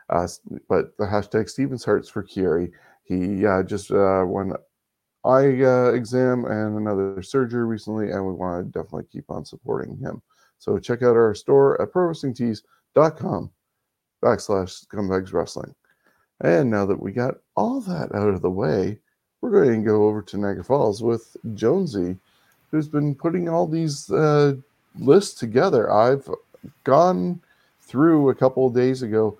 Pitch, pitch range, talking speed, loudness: 120 Hz, 105-140 Hz, 155 wpm, -22 LUFS